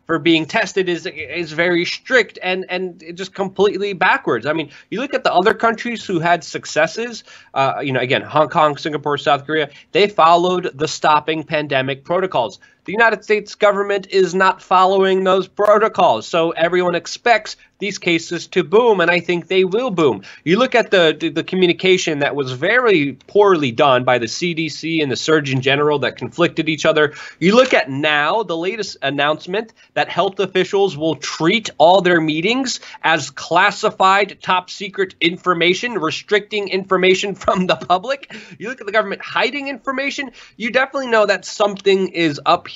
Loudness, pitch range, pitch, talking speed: -17 LUFS, 160-205 Hz, 185 Hz, 175 wpm